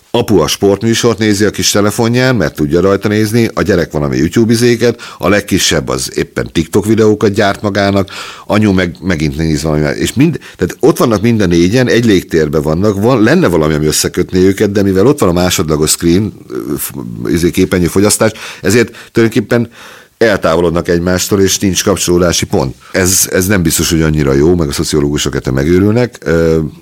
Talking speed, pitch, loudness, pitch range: 170 wpm, 95 Hz, -11 LUFS, 80-105 Hz